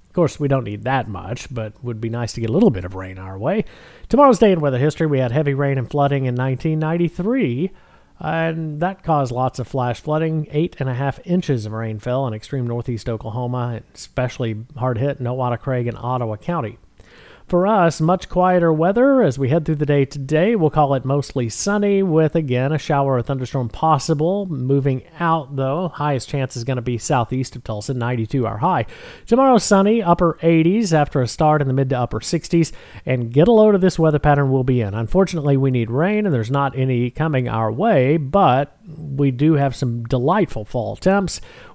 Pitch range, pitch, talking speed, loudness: 125-165 Hz, 140 Hz, 205 wpm, -19 LUFS